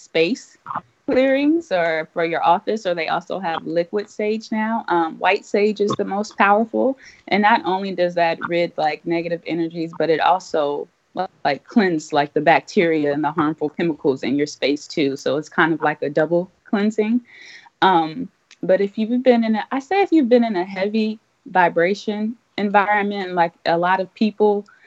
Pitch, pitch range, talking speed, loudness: 185 Hz, 165-215 Hz, 180 wpm, -20 LUFS